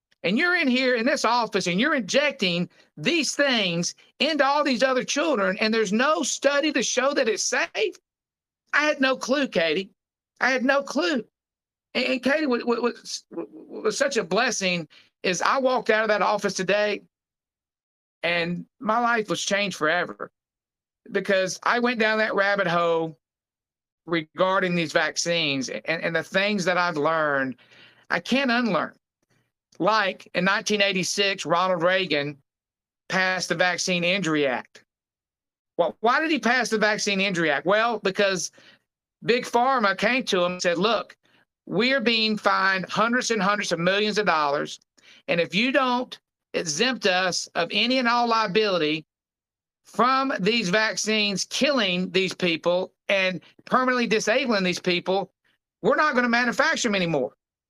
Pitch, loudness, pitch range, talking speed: 210 Hz, -23 LUFS, 180-250 Hz, 150 wpm